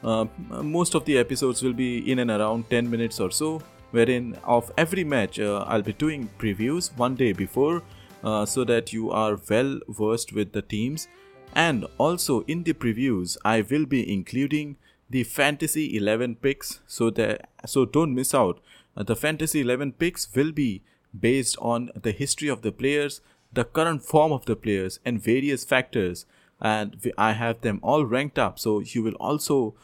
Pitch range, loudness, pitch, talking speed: 110-145 Hz, -25 LUFS, 125 Hz, 175 wpm